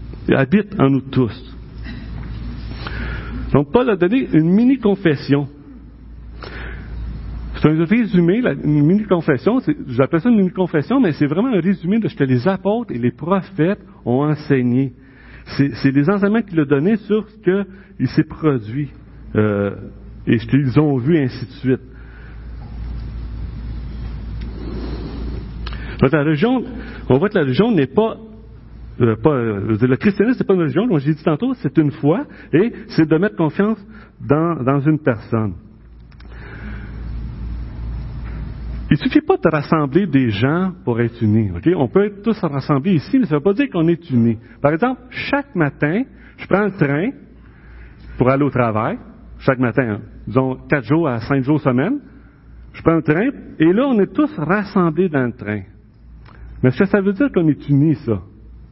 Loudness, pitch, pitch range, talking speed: -17 LUFS, 150 Hz, 125-190 Hz, 165 wpm